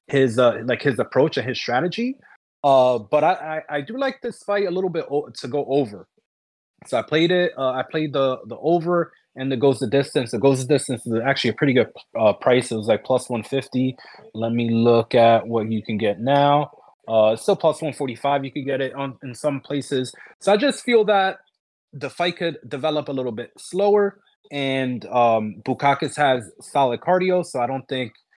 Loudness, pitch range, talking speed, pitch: -21 LUFS, 125-160 Hz, 210 wpm, 140 Hz